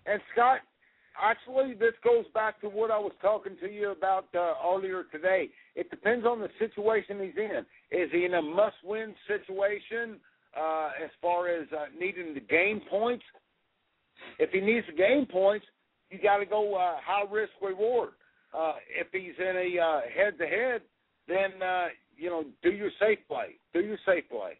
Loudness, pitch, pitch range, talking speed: -30 LUFS, 205 Hz, 185-230 Hz, 180 wpm